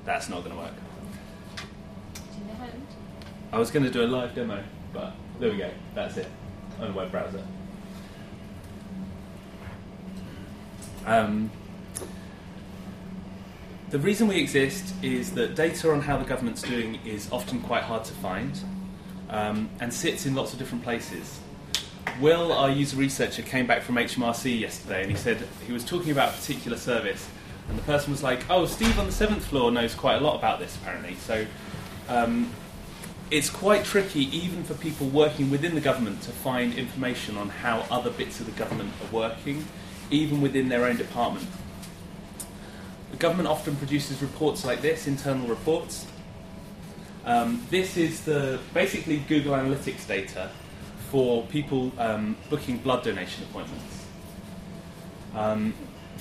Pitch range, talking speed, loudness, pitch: 110-155 Hz, 150 wpm, -27 LUFS, 130 Hz